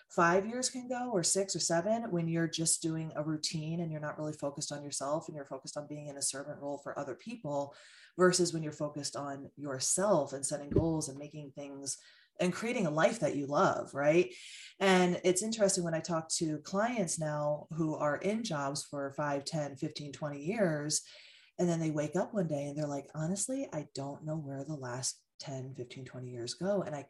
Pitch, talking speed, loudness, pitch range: 155 Hz, 215 wpm, -34 LUFS, 145-180 Hz